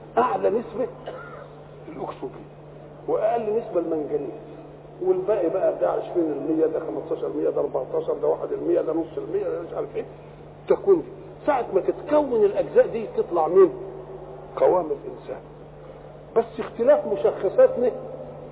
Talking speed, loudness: 115 wpm, -23 LUFS